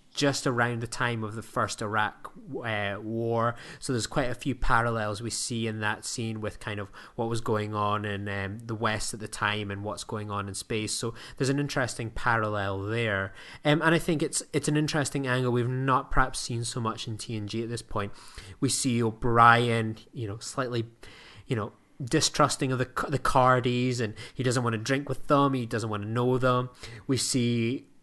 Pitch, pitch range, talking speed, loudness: 115 Hz, 110-130 Hz, 205 wpm, -28 LUFS